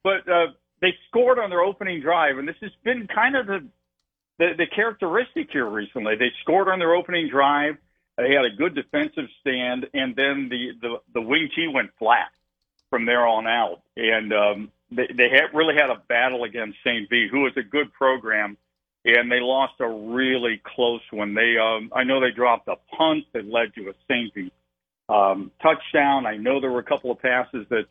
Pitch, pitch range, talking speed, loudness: 130 Hz, 115-170 Hz, 200 wpm, -22 LUFS